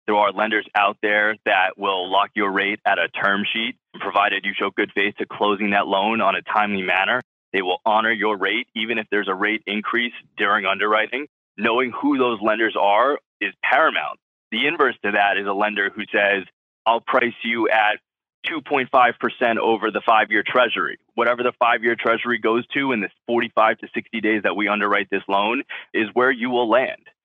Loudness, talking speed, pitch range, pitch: -20 LUFS, 195 wpm, 105-120 Hz, 110 Hz